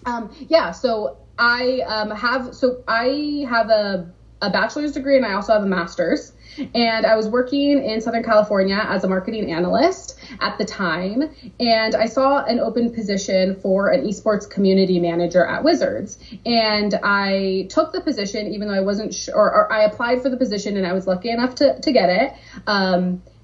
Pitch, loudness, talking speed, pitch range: 220 Hz, -19 LUFS, 185 wpm, 195-255 Hz